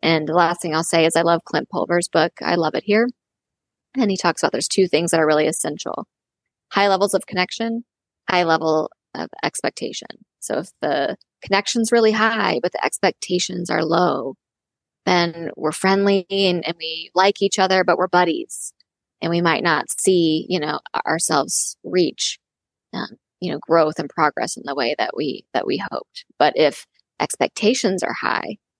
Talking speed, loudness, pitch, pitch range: 180 wpm, -20 LUFS, 180 Hz, 165-200 Hz